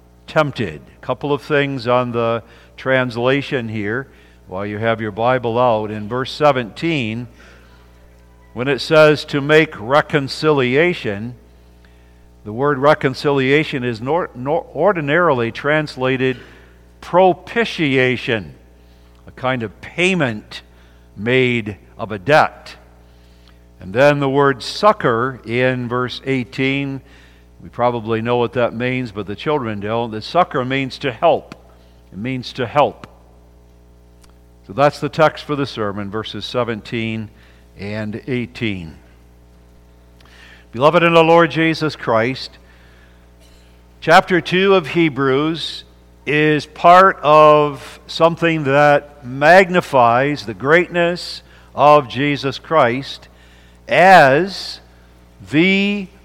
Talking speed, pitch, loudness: 110 wpm, 120 Hz, -16 LUFS